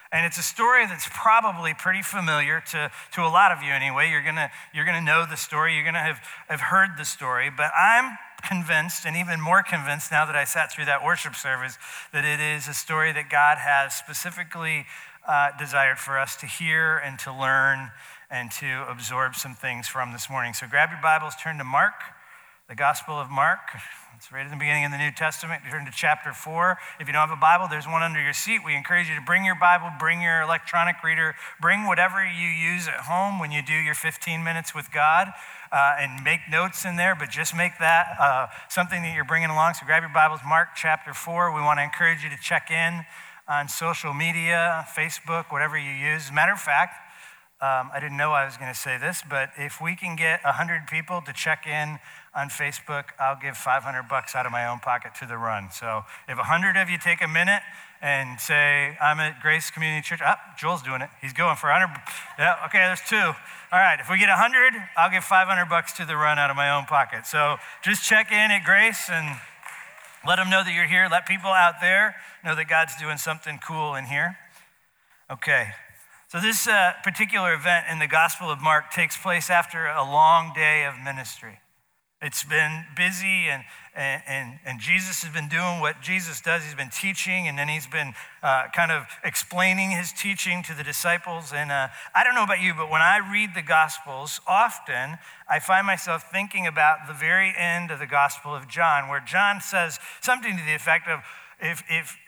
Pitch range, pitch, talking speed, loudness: 145-175 Hz, 160 Hz, 215 wpm, -23 LUFS